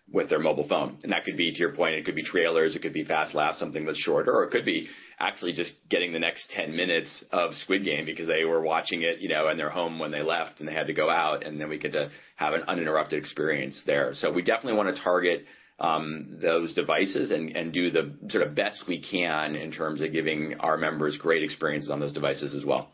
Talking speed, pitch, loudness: 250 wpm, 80 Hz, -27 LUFS